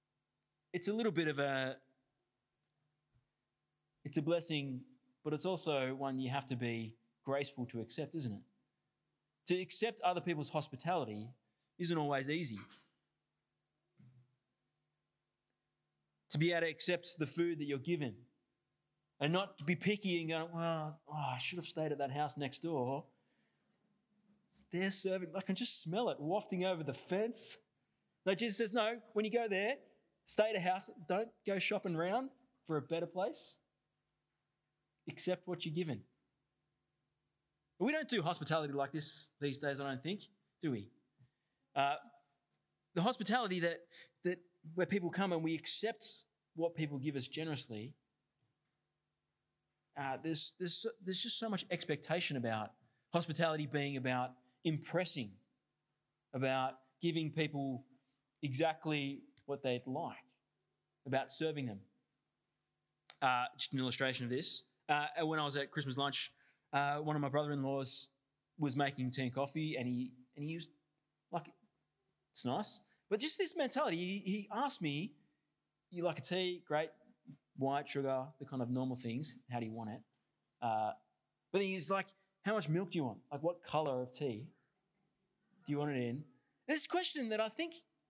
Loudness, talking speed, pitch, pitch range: -38 LUFS, 155 wpm, 150 Hz, 135-180 Hz